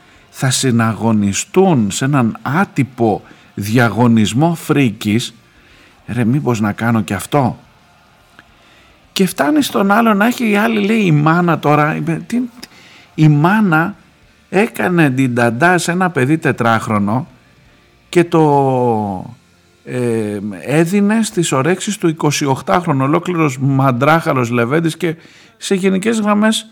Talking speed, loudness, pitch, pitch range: 110 wpm, -14 LUFS, 150 Hz, 120-180 Hz